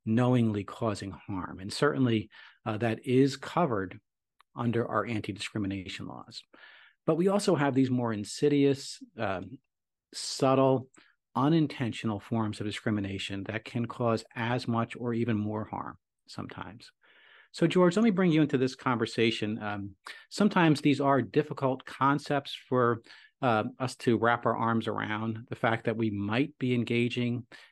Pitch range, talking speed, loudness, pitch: 110-140 Hz, 145 wpm, -29 LUFS, 120 Hz